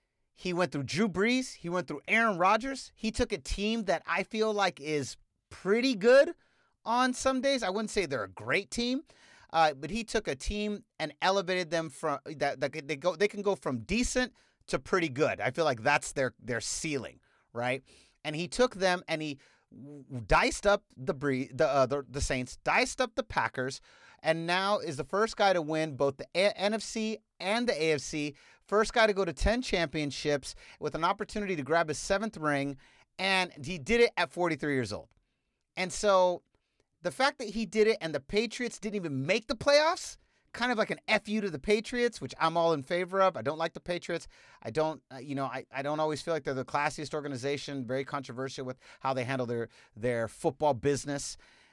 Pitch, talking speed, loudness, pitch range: 175 Hz, 205 wpm, -30 LUFS, 145-215 Hz